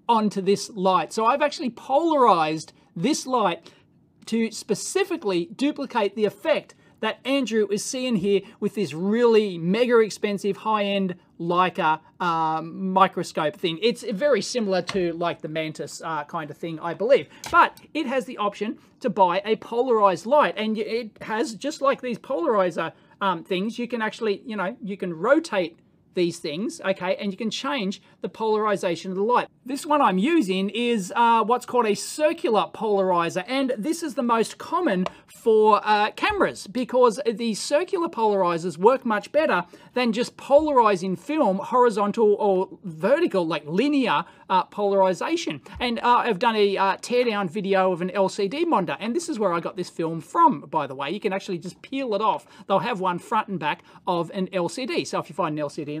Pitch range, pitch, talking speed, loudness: 185-245 Hz, 210 Hz, 180 wpm, -23 LUFS